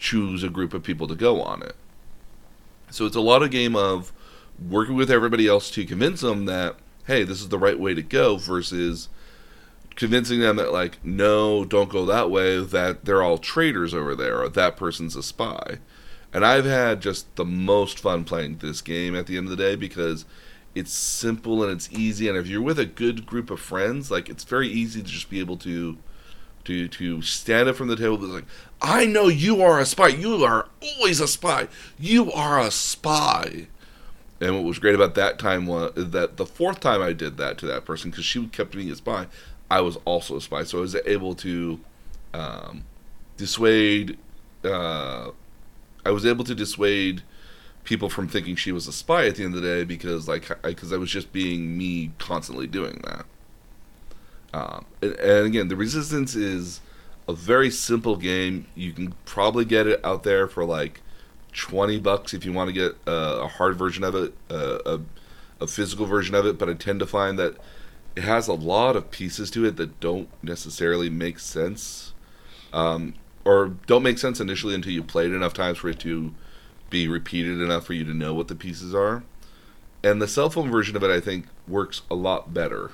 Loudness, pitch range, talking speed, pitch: -23 LUFS, 85-110 Hz, 205 wpm, 95 Hz